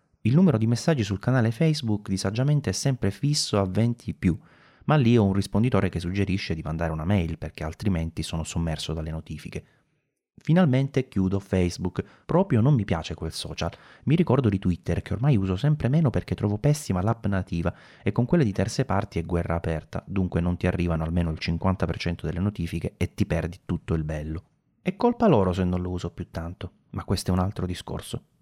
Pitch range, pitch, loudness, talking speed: 85-120 Hz, 95 Hz, -26 LUFS, 195 wpm